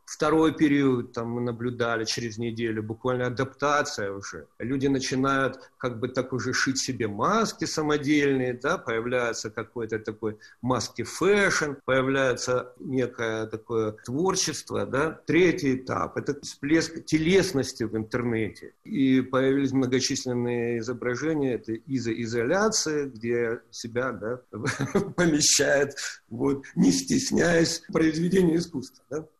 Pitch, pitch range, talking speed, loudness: 130 Hz, 115-145 Hz, 110 wpm, -26 LUFS